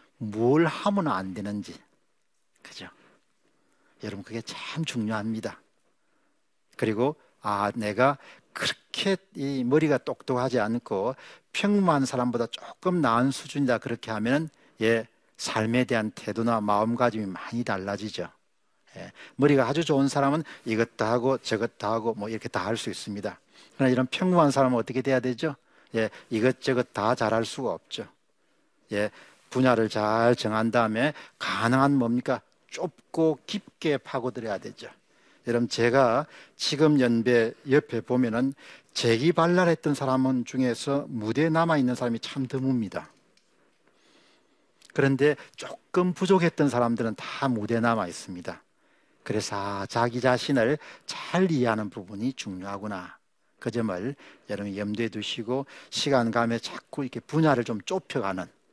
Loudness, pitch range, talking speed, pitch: -27 LUFS, 110-140 Hz, 285 characters per minute, 120 Hz